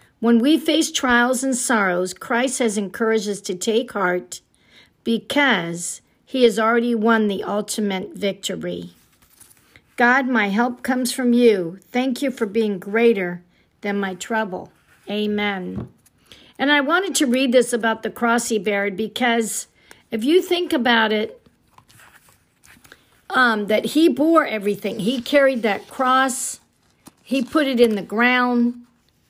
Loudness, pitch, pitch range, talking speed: -20 LUFS, 230 Hz, 205-255 Hz, 140 wpm